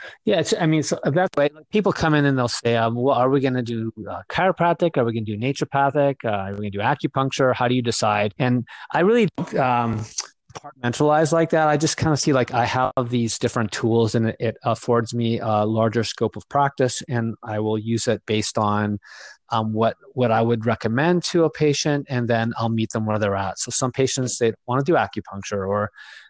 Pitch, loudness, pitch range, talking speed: 120 Hz, -21 LUFS, 110-145 Hz, 230 wpm